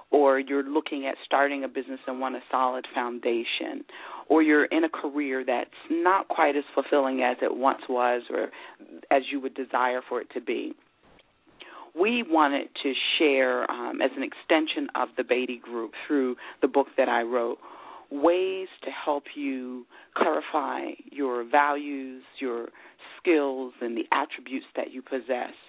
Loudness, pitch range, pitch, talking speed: -27 LUFS, 125-150 Hz, 135 Hz, 160 wpm